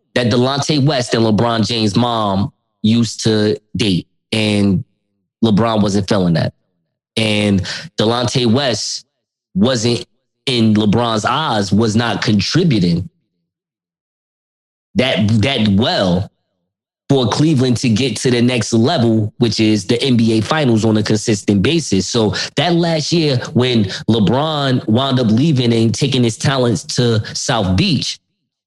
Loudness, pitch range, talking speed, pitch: -15 LUFS, 105-125 Hz, 130 wpm, 115 Hz